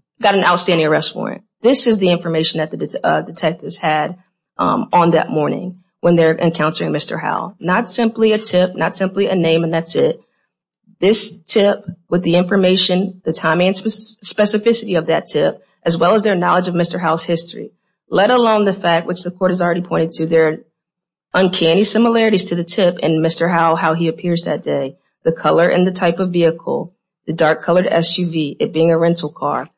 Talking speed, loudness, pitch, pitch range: 195 wpm, -15 LUFS, 175 Hz, 165-195 Hz